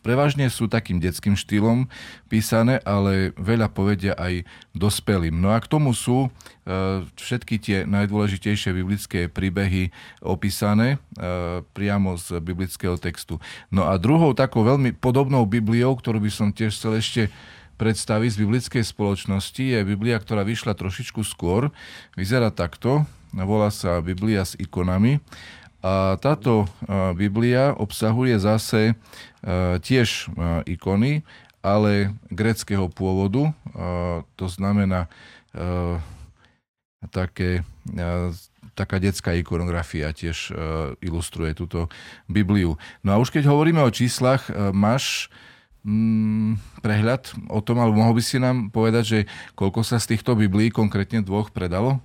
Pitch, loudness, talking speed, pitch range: 105 Hz, -22 LUFS, 120 wpm, 95-115 Hz